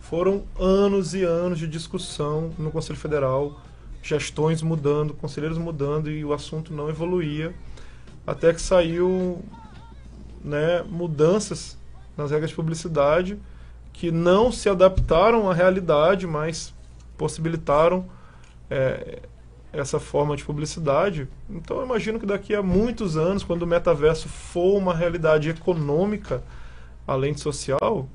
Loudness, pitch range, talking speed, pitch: -23 LUFS, 145-180 Hz, 125 wpm, 160 Hz